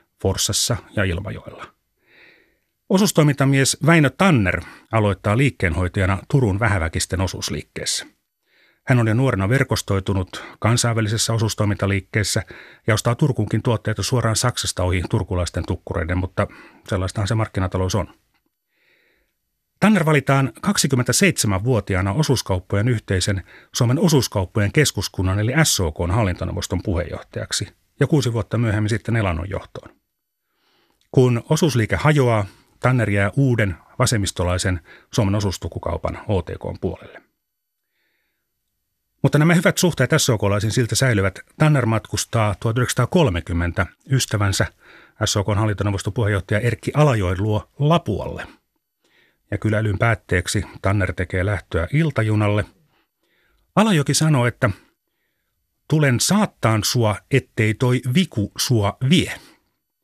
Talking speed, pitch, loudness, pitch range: 95 wpm, 110 Hz, -20 LUFS, 100-130 Hz